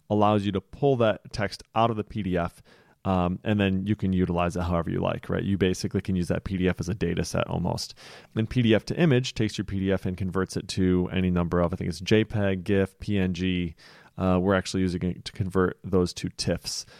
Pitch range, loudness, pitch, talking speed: 90-105 Hz, -26 LUFS, 95 Hz, 220 wpm